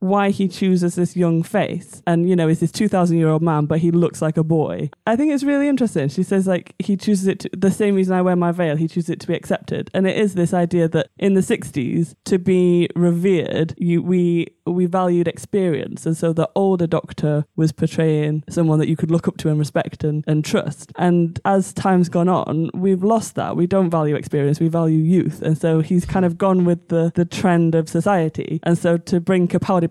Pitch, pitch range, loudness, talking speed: 175 Hz, 160-185 Hz, -19 LUFS, 230 wpm